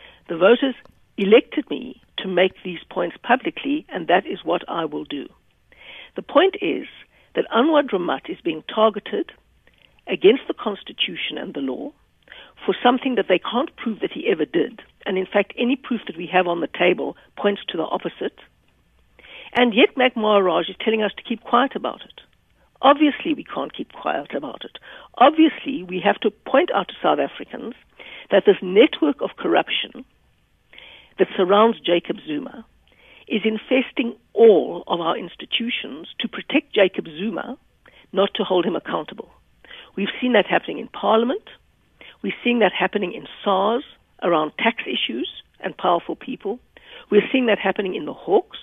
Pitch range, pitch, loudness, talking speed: 195-280 Hz, 230 Hz, -21 LUFS, 165 wpm